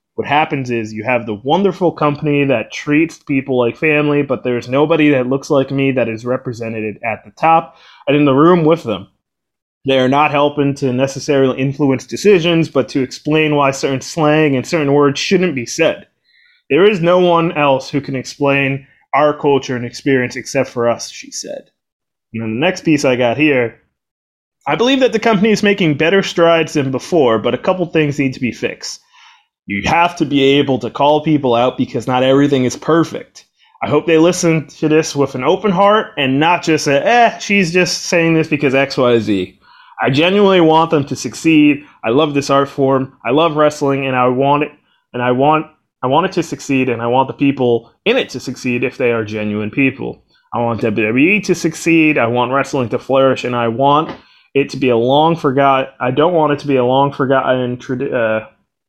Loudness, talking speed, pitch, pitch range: -14 LUFS, 205 wpm, 140 Hz, 125-160 Hz